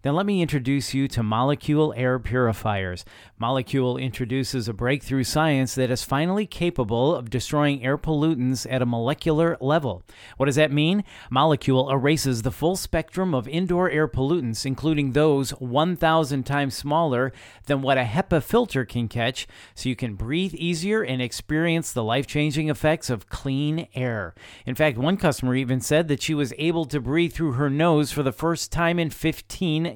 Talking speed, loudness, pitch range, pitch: 175 wpm, -23 LUFS, 125-160 Hz, 140 Hz